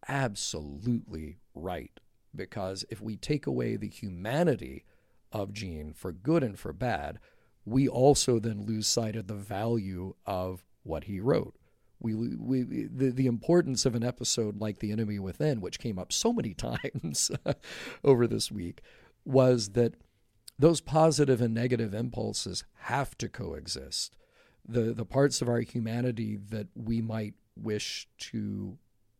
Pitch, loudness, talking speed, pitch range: 115 Hz, -30 LUFS, 145 wpm, 100-125 Hz